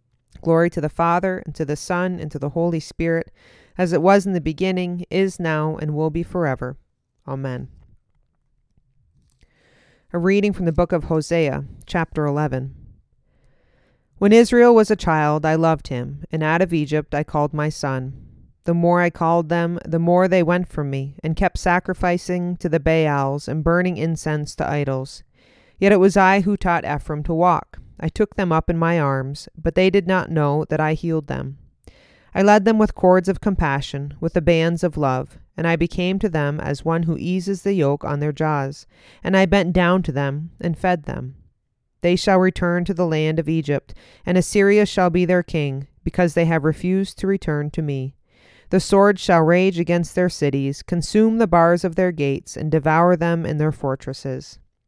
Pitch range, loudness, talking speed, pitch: 150-180 Hz, -20 LUFS, 190 wpm, 165 Hz